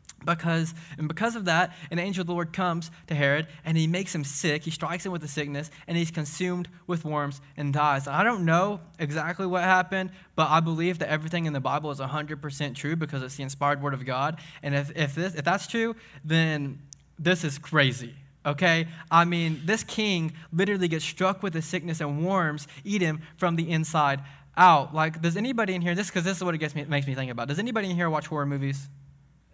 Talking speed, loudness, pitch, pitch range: 225 wpm, -27 LUFS, 160 Hz, 145-180 Hz